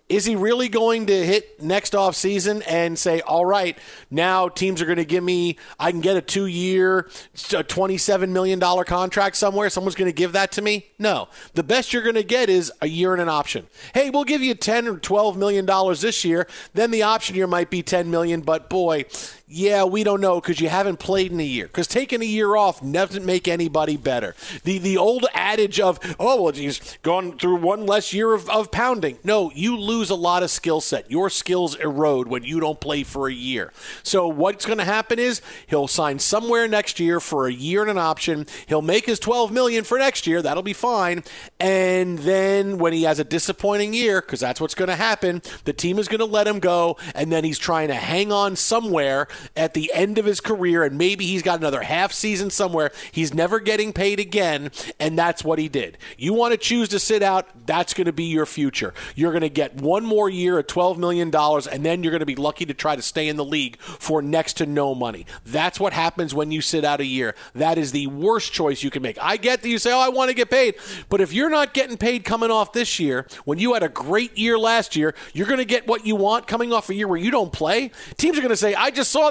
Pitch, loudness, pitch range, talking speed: 185 Hz, -21 LUFS, 165-210 Hz, 240 wpm